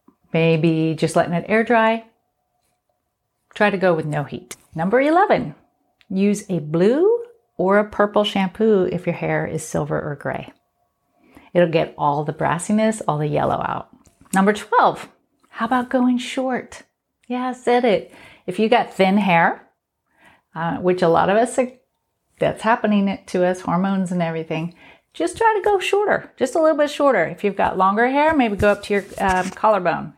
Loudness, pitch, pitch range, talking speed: -19 LUFS, 205 Hz, 175-250 Hz, 175 wpm